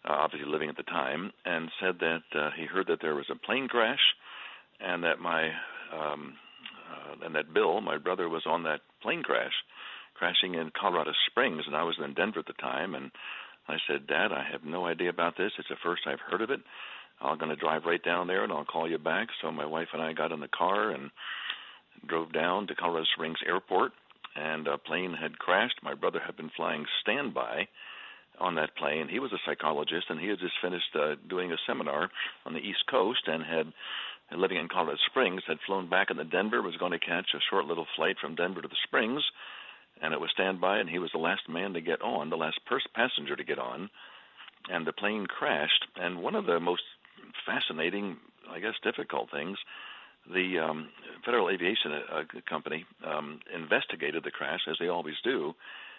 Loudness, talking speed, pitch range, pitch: -31 LUFS, 205 wpm, 80-90 Hz, 80 Hz